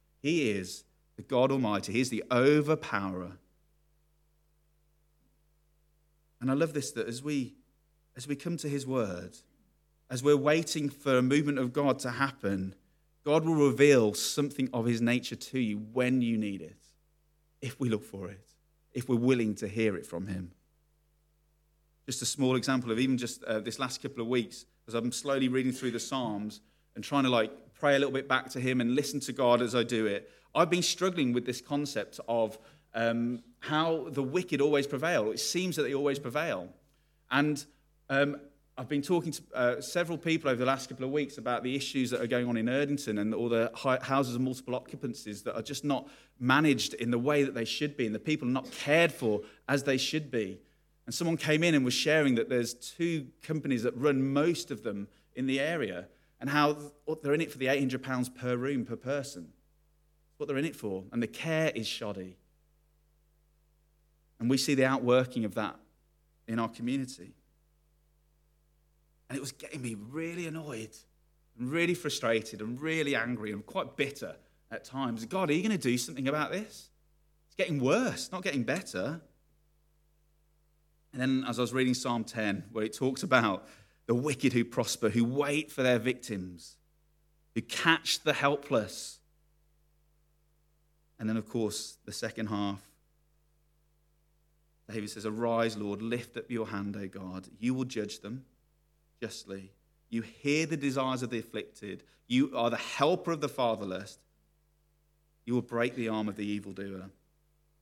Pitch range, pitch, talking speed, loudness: 115-150 Hz, 135 Hz, 180 wpm, -31 LUFS